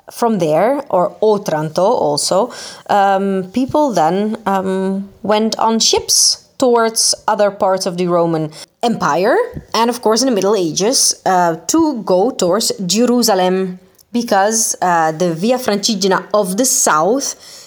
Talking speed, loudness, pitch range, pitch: 130 wpm, -14 LUFS, 185-235 Hz, 205 Hz